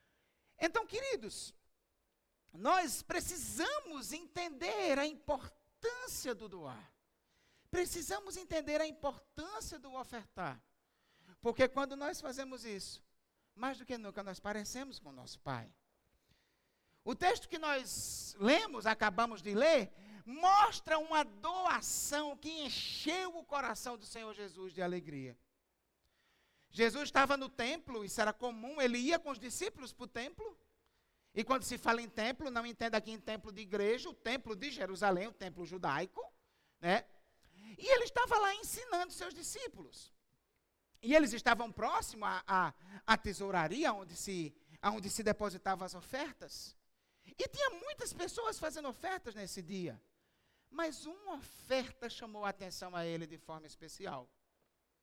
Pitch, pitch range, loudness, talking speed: 245 Hz, 205-310 Hz, -37 LUFS, 140 wpm